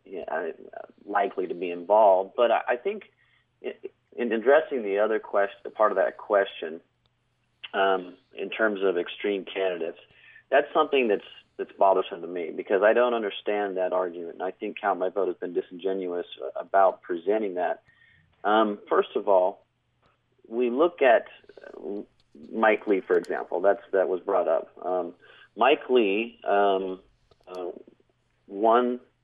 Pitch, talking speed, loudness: 105 Hz, 145 wpm, -25 LUFS